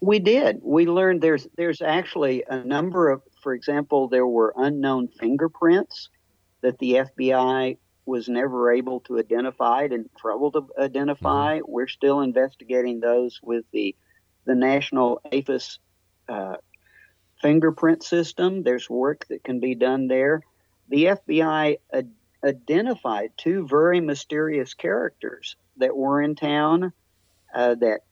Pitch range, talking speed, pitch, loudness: 125-150 Hz, 130 wpm, 135 Hz, -23 LUFS